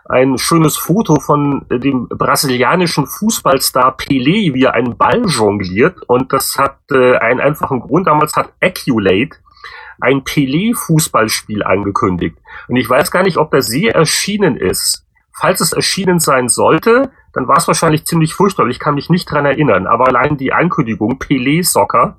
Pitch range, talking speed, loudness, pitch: 130-170 Hz, 155 wpm, -13 LUFS, 145 Hz